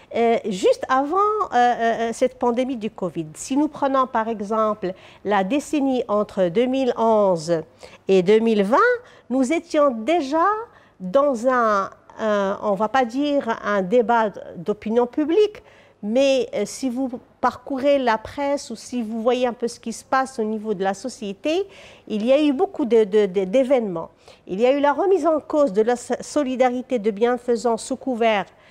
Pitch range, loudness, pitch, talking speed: 215-275 Hz, -21 LUFS, 245 Hz, 165 wpm